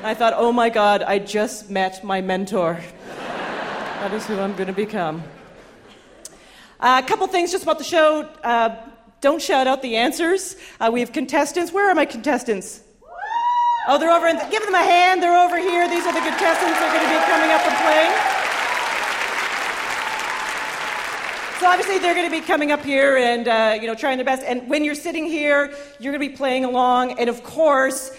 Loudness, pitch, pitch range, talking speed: -19 LUFS, 275 Hz, 230-340 Hz, 200 wpm